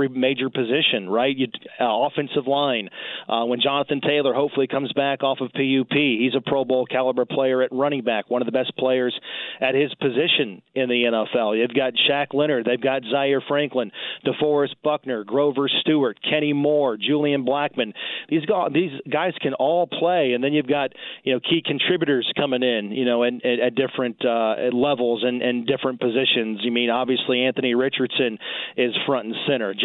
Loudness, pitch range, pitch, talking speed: -22 LUFS, 125-145 Hz, 135 Hz, 185 wpm